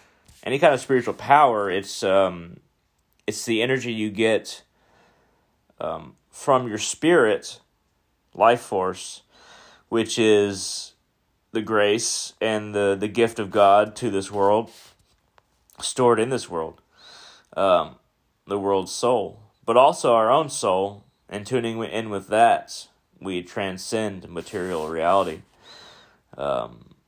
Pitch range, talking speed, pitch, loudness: 95-115 Hz, 120 wpm, 105 Hz, -22 LUFS